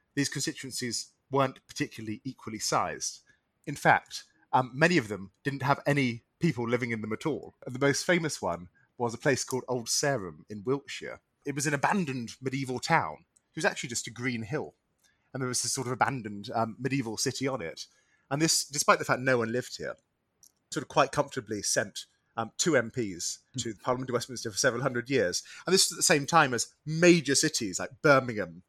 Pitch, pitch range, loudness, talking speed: 130 Hz, 120-145 Hz, -29 LUFS, 205 wpm